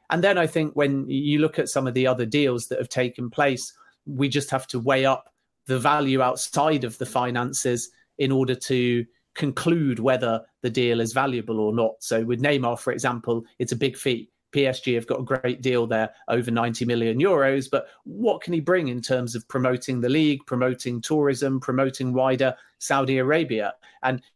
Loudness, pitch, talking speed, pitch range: -24 LUFS, 130 Hz, 190 wpm, 120-140 Hz